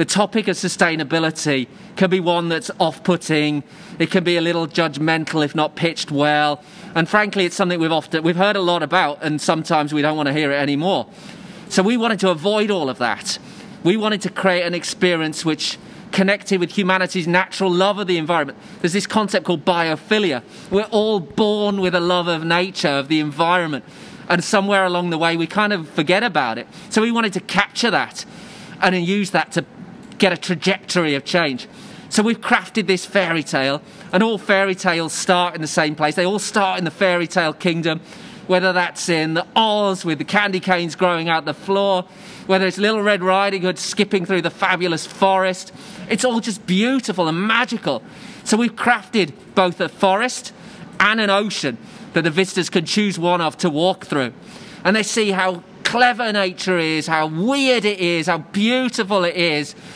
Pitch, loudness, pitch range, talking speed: 185 Hz, -19 LUFS, 165-205 Hz, 190 wpm